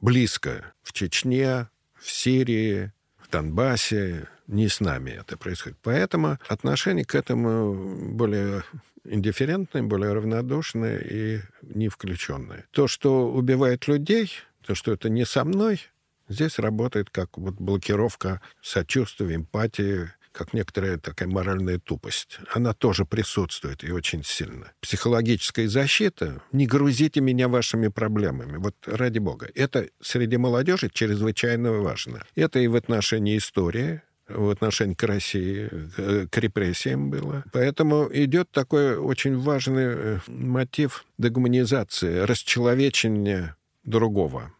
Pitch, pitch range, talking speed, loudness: 110 Hz, 100-130 Hz, 115 wpm, -25 LUFS